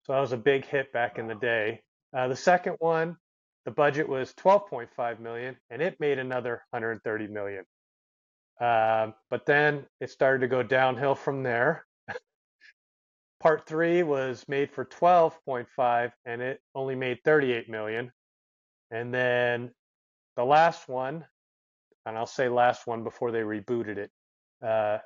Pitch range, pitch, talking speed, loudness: 115-140 Hz, 125 Hz, 150 wpm, -27 LUFS